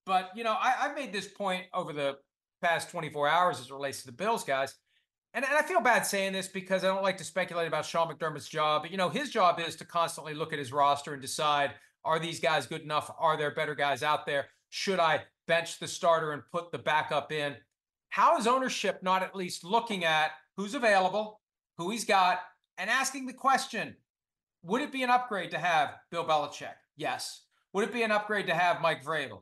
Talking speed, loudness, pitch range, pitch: 220 wpm, -30 LUFS, 155-200 Hz, 170 Hz